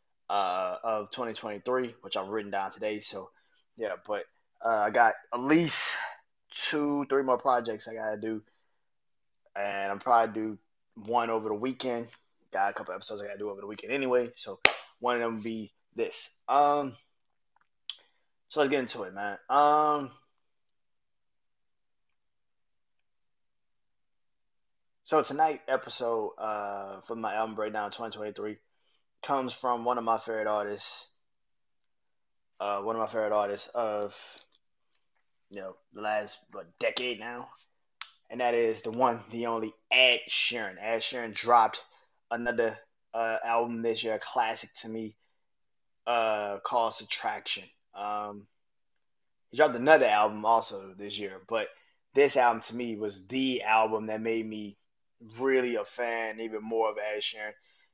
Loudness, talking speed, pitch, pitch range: -30 LUFS, 145 wpm, 115 Hz, 105-125 Hz